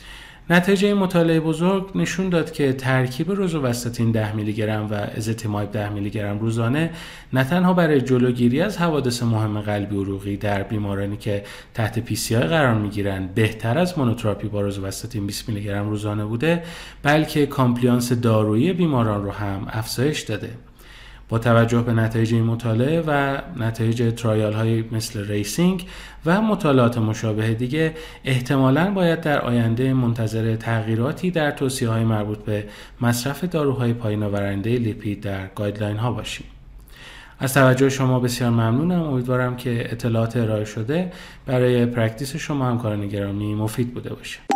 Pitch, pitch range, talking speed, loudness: 120 Hz, 110-140 Hz, 145 wpm, -21 LUFS